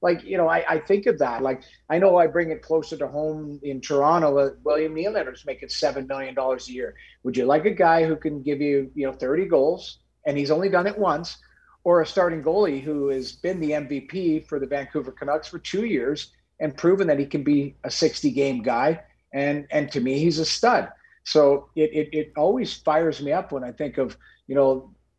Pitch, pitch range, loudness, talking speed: 150 Hz, 140-160 Hz, -23 LUFS, 220 wpm